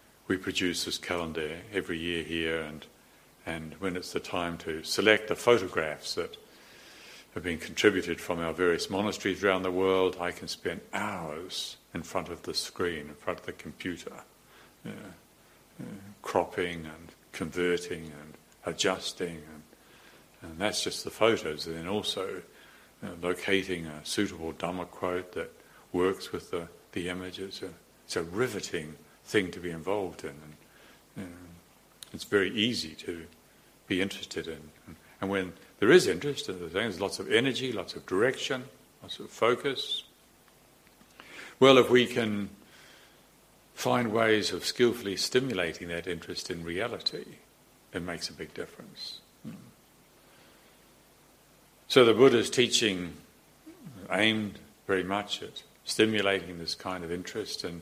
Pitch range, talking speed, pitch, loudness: 85-100 Hz, 145 wpm, 90 Hz, -30 LUFS